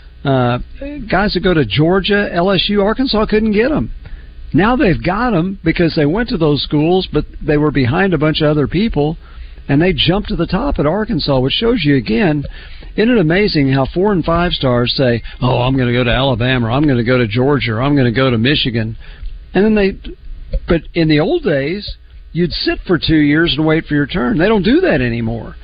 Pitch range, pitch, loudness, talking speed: 130-185 Hz, 150 Hz, -14 LUFS, 220 wpm